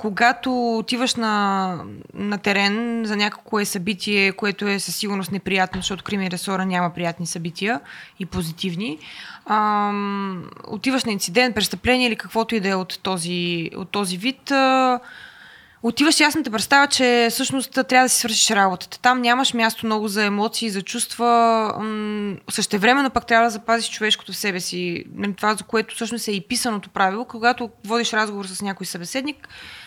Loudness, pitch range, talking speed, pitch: -21 LUFS, 195-235 Hz, 165 wpm, 215 Hz